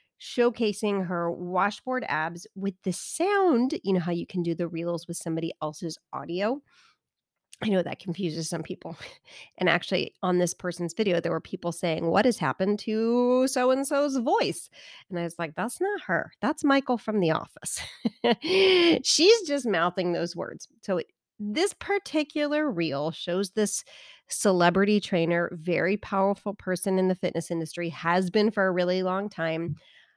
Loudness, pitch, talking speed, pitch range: -26 LUFS, 190 Hz, 165 wpm, 170-250 Hz